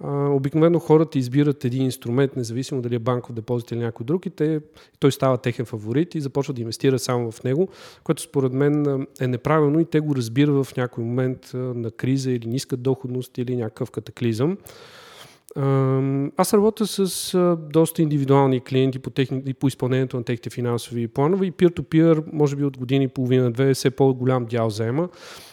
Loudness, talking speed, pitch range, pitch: -22 LUFS, 170 wpm, 125-150 Hz, 135 Hz